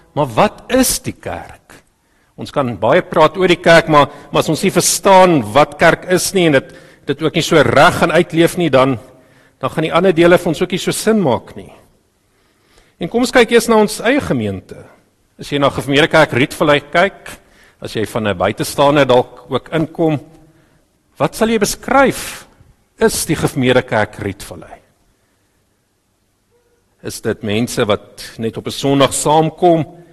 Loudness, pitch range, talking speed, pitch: -14 LUFS, 125-175 Hz, 175 wpm, 155 Hz